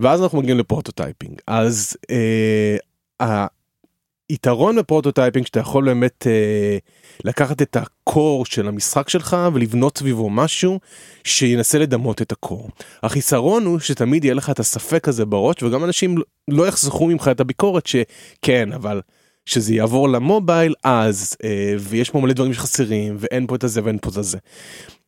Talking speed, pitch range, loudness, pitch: 145 wpm, 110-150 Hz, -18 LUFS, 130 Hz